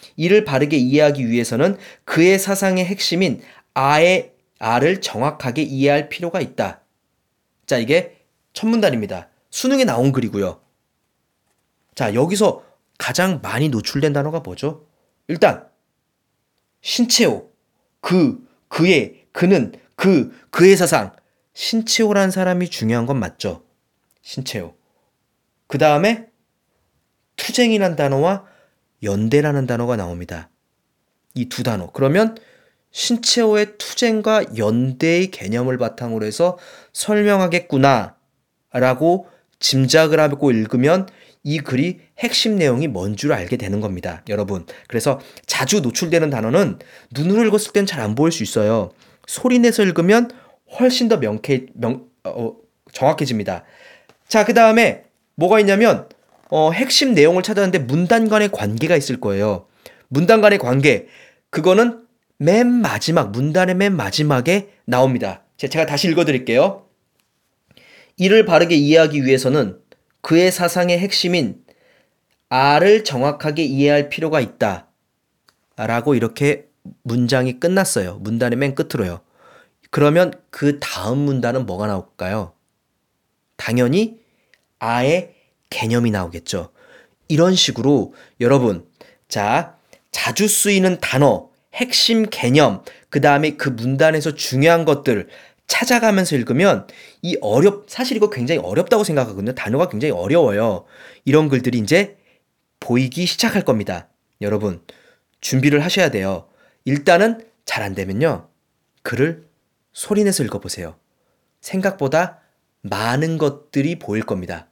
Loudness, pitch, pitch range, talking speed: -17 LUFS, 155 Hz, 125-200 Hz, 270 characters per minute